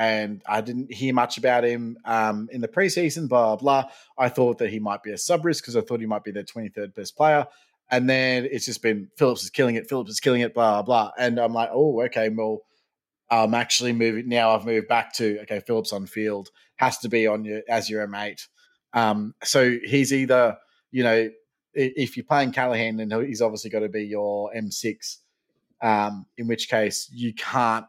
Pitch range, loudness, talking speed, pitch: 110-125 Hz, -23 LUFS, 220 wpm, 115 Hz